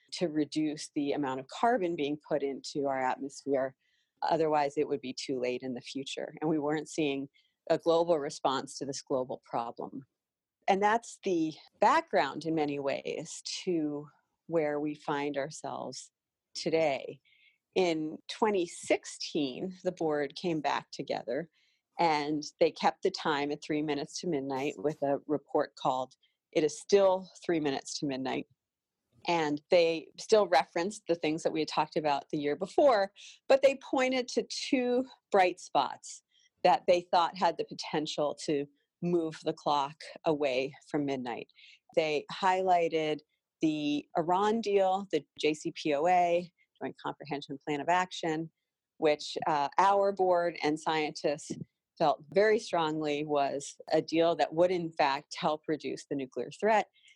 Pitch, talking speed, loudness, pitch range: 155 Hz, 145 wpm, -31 LUFS, 145-180 Hz